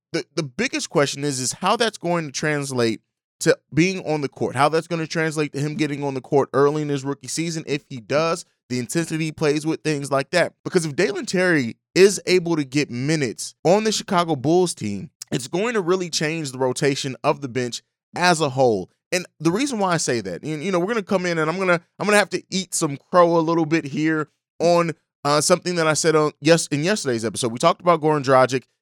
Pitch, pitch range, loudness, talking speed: 160 Hz, 140-175 Hz, -21 LUFS, 240 wpm